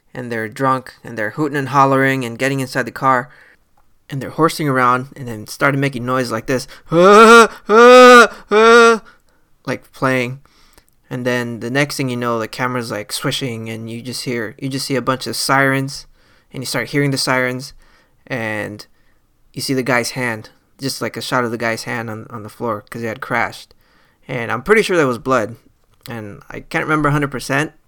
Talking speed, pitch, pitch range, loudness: 195 wpm, 130 Hz, 120-140 Hz, -15 LUFS